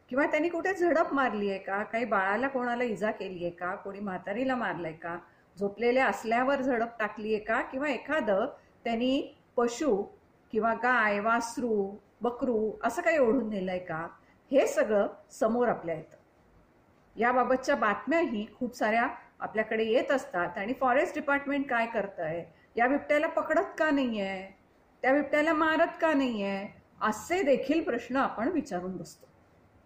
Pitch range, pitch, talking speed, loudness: 200-275 Hz, 235 Hz, 140 wpm, -29 LUFS